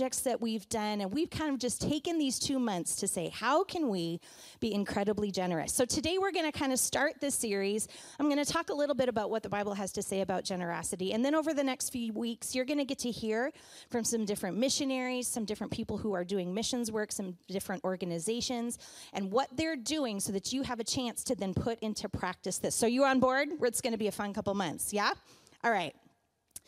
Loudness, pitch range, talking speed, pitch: -33 LUFS, 205-270 Hz, 235 wpm, 230 Hz